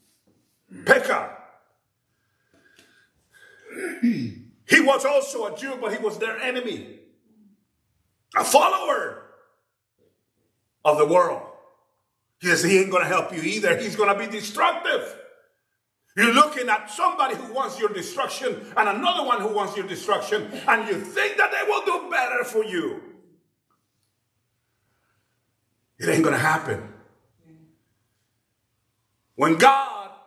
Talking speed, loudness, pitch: 125 wpm, -22 LUFS, 205 Hz